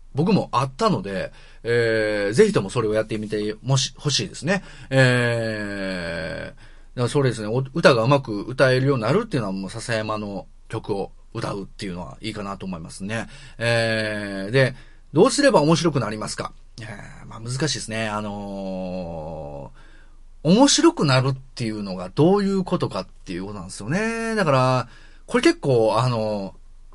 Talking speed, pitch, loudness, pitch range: 335 characters per minute, 115 Hz, -22 LUFS, 105-140 Hz